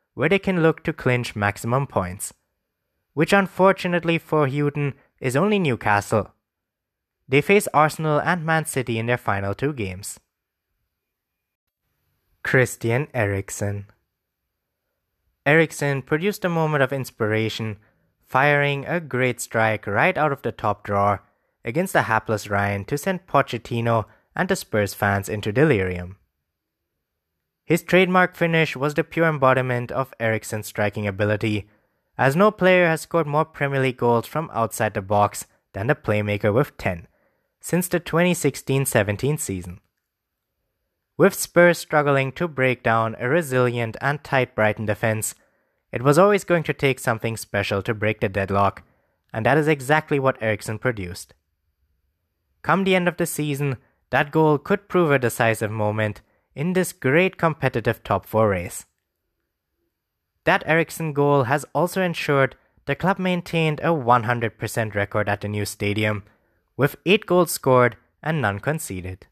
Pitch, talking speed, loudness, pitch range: 120 Hz, 145 wpm, -21 LUFS, 105-155 Hz